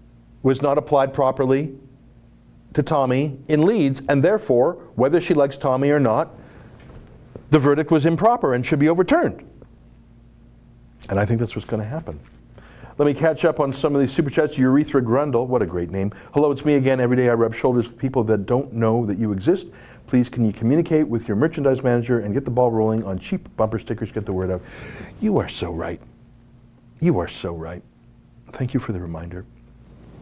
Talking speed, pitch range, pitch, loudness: 195 wpm, 115-145 Hz, 125 Hz, -20 LUFS